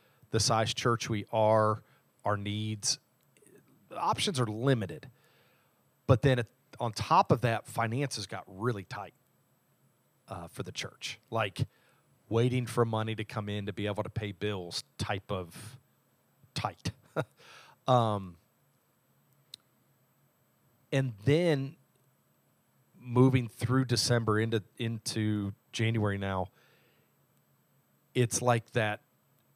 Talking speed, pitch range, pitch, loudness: 110 wpm, 105-130 Hz, 115 Hz, -31 LUFS